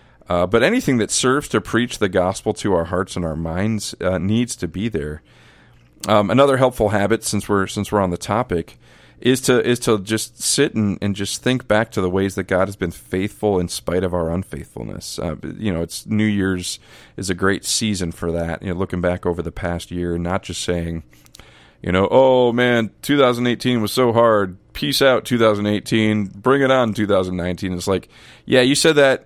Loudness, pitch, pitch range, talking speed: -19 LUFS, 105 Hz, 90-120 Hz, 205 wpm